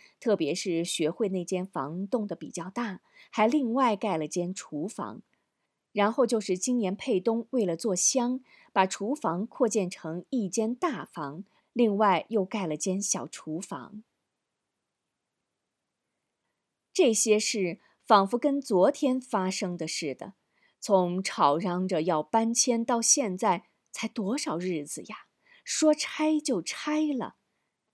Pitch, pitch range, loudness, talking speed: 210 Hz, 180-245 Hz, -28 LUFS, 185 characters per minute